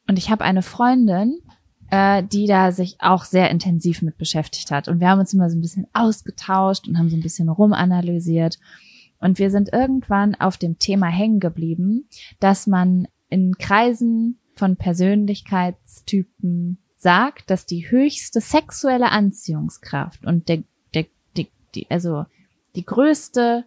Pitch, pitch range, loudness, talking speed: 190 Hz, 175-210 Hz, -19 LUFS, 150 wpm